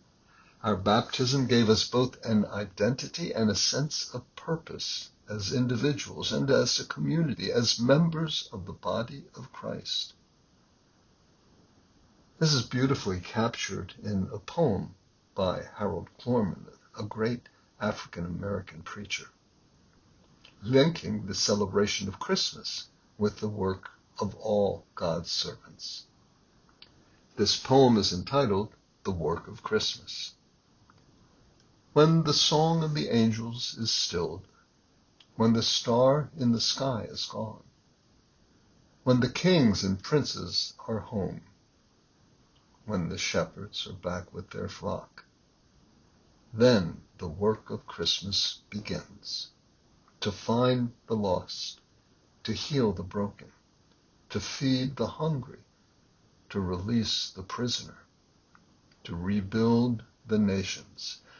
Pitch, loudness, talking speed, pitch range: 115 Hz, -29 LUFS, 115 wpm, 100-130 Hz